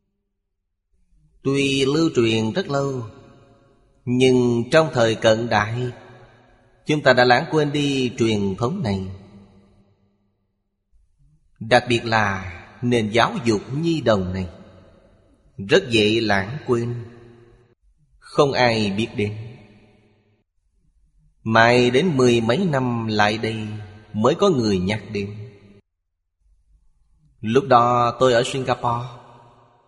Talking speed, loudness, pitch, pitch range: 105 wpm, -19 LUFS, 115 Hz, 100-125 Hz